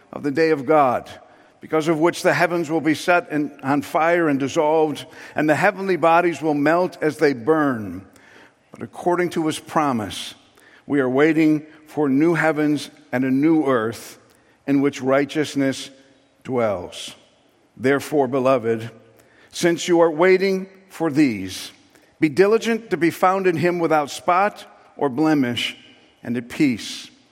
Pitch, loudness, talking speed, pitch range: 155 Hz, -20 LUFS, 150 wpm, 140-170 Hz